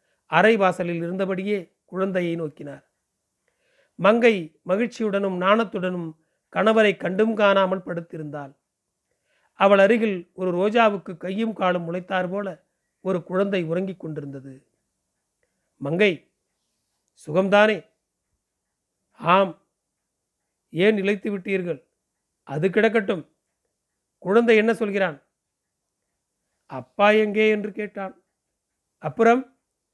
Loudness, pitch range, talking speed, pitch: -22 LUFS, 175-215 Hz, 80 wpm, 195 Hz